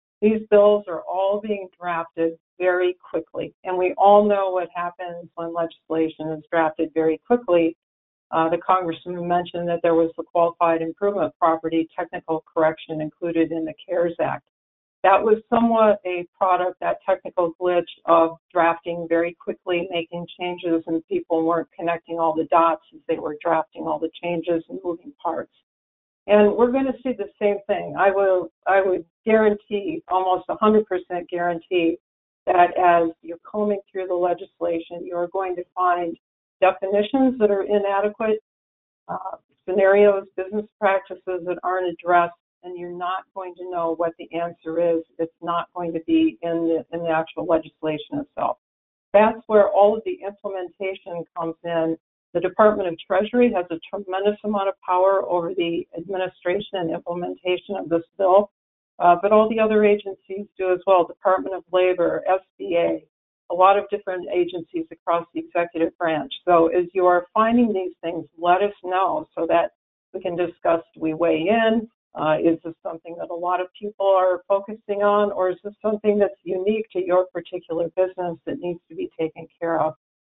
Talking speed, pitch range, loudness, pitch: 165 wpm, 165-195 Hz, -22 LUFS, 180 Hz